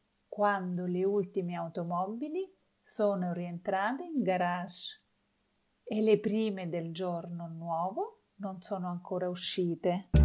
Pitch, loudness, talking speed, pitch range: 185 Hz, -33 LUFS, 105 wpm, 175-210 Hz